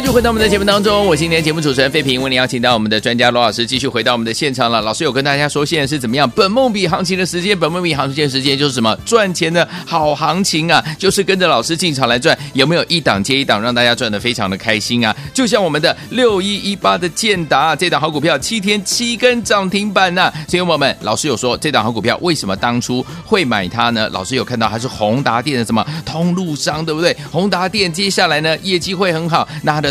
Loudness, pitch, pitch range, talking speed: -14 LUFS, 155 Hz, 125-185 Hz, 385 characters per minute